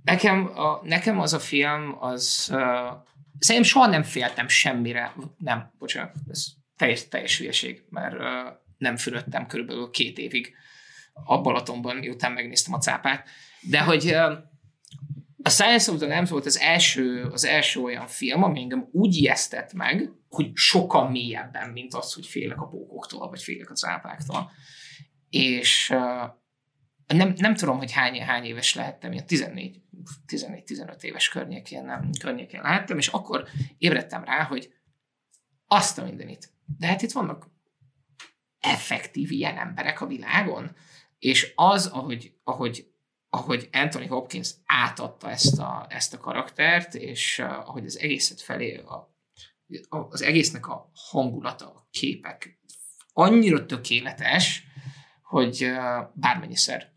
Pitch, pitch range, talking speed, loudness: 145 Hz, 125-165 Hz, 130 wpm, -24 LUFS